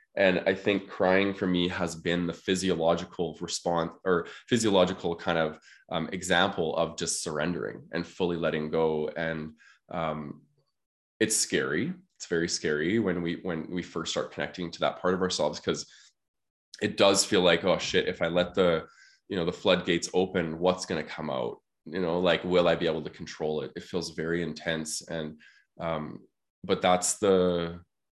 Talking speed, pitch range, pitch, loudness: 175 wpm, 80-90 Hz, 85 Hz, -28 LUFS